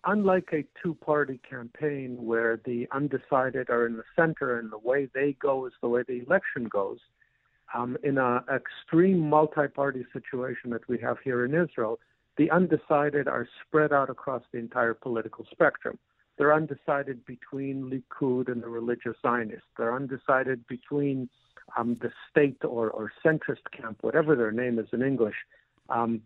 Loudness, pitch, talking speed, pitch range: -28 LUFS, 130 Hz, 160 wpm, 120-150 Hz